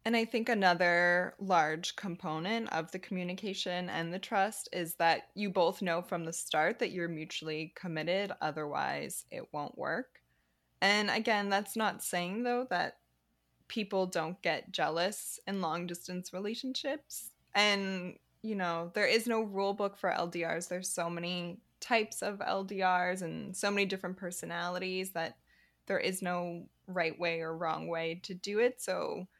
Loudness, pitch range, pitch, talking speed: -34 LUFS, 170-200 Hz, 180 Hz, 155 wpm